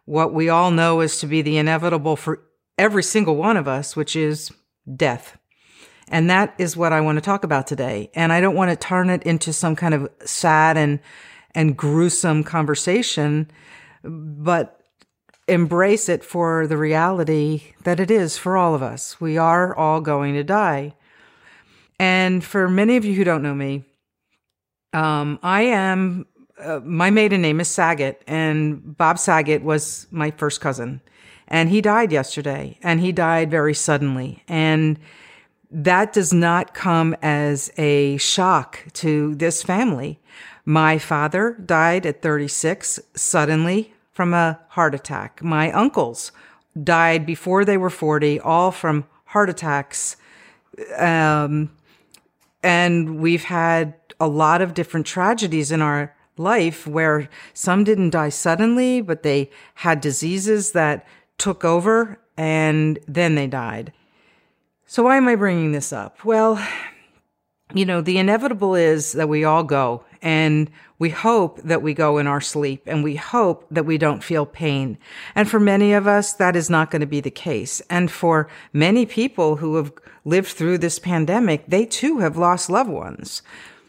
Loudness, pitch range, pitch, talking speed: -19 LUFS, 150-185 Hz, 165 Hz, 155 wpm